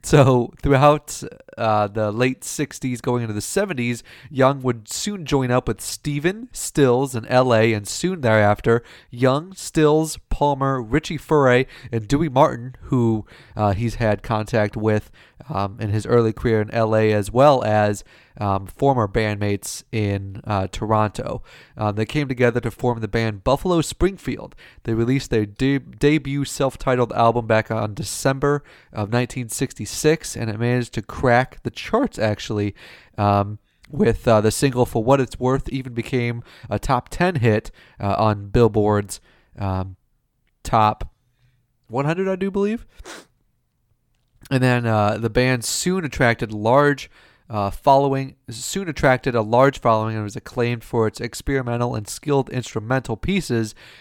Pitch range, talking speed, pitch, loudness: 110-135 Hz, 150 wpm, 120 Hz, -21 LUFS